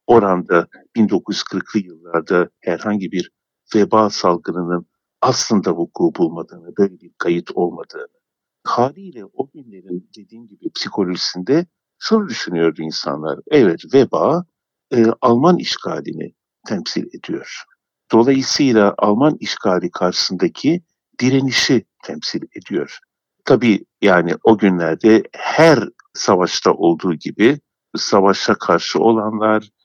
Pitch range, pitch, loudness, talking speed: 90-135 Hz, 110 Hz, -17 LUFS, 95 wpm